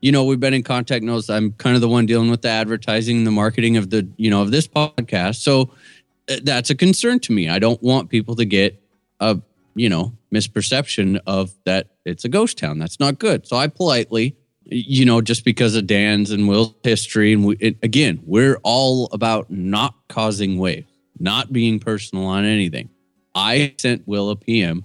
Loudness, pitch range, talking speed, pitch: -18 LUFS, 105-130 Hz, 200 wpm, 115 Hz